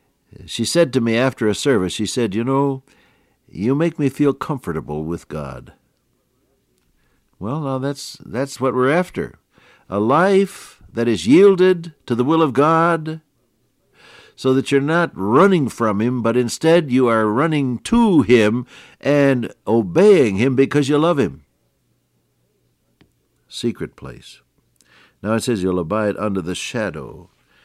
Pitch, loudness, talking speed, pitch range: 130 Hz, -18 LUFS, 145 wpm, 110-150 Hz